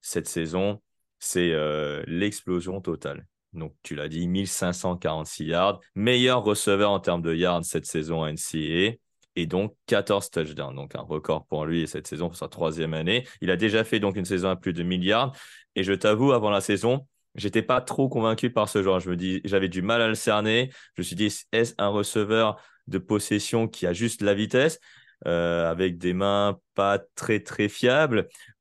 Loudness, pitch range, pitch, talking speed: -25 LUFS, 85-110 Hz, 95 Hz, 195 wpm